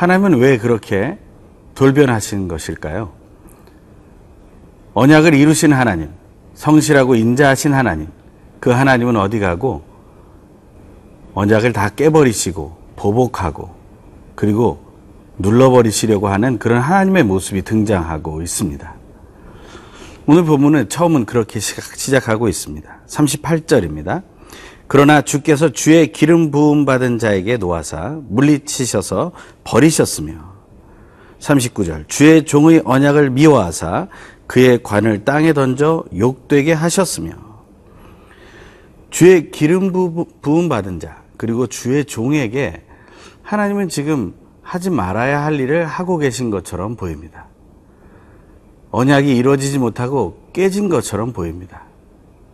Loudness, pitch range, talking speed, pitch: -14 LUFS, 100-150 Hz, 260 characters per minute, 125 Hz